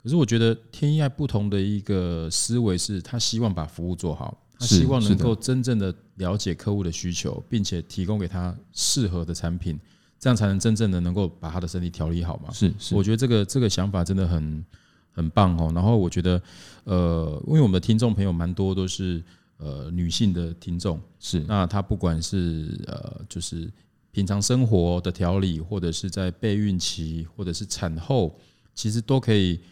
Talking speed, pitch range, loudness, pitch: 285 characters per minute, 85-110 Hz, -24 LUFS, 95 Hz